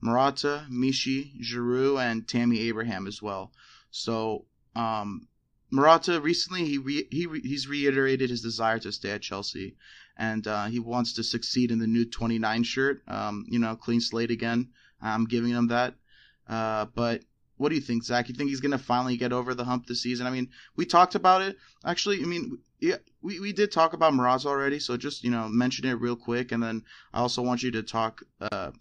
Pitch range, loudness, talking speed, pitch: 115-140 Hz, -27 LUFS, 205 wpm, 120 Hz